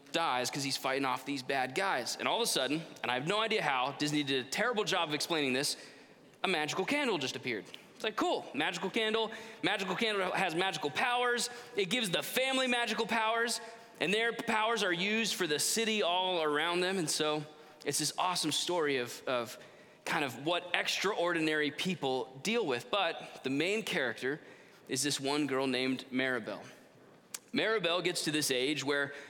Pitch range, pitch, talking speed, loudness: 145-220 Hz, 175 Hz, 185 wpm, -32 LUFS